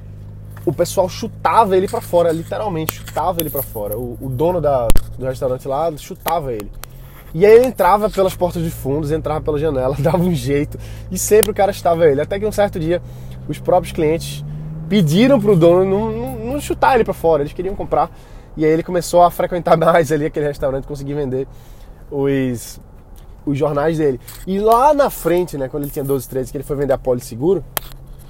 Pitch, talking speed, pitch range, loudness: 155 Hz, 195 wpm, 130-175 Hz, -17 LUFS